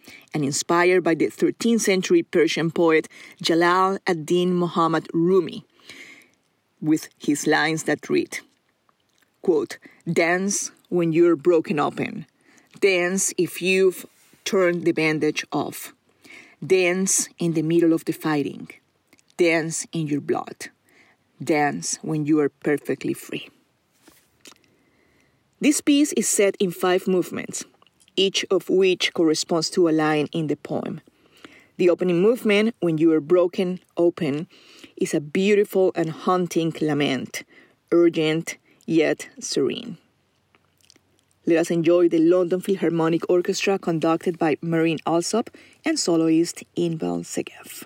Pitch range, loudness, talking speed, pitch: 160-195 Hz, -22 LUFS, 120 wpm, 175 Hz